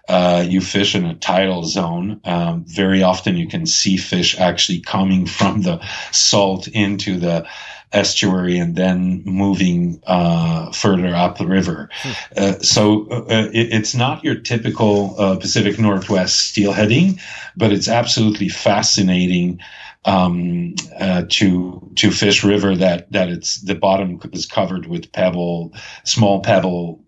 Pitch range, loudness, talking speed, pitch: 90-105 Hz, -16 LUFS, 140 wpm, 95 Hz